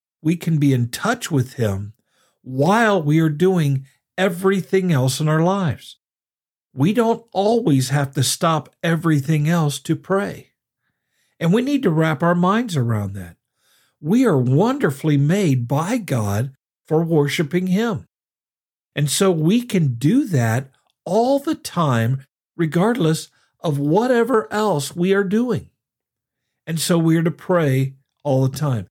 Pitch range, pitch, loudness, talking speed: 135-190 Hz, 155 Hz, -19 LUFS, 145 wpm